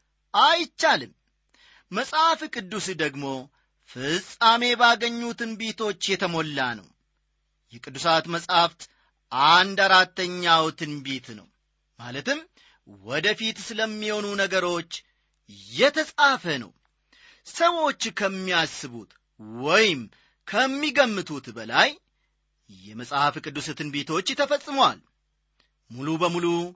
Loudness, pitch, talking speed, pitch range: -23 LUFS, 185 Hz, 70 wpm, 150-235 Hz